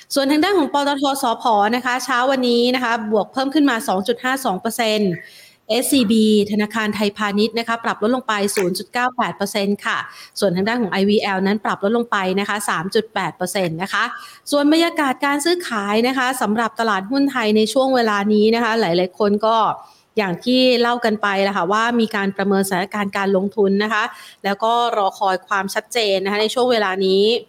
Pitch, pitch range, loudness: 220 Hz, 200-245 Hz, -18 LUFS